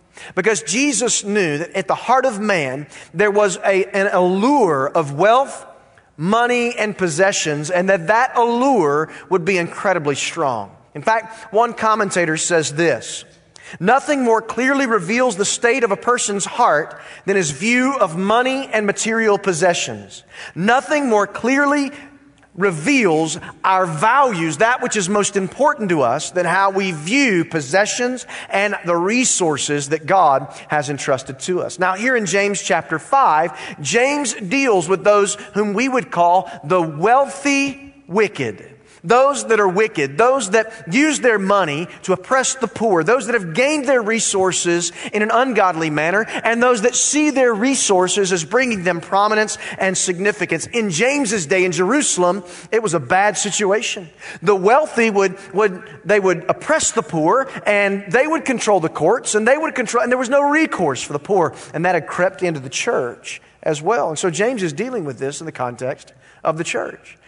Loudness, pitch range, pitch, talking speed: -17 LUFS, 175-240 Hz, 205 Hz, 170 wpm